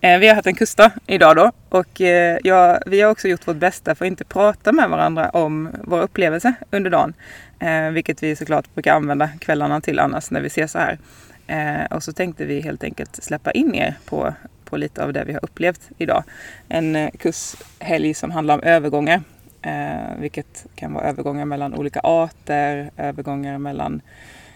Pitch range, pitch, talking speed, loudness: 150-185 Hz, 165 Hz, 175 wpm, -18 LUFS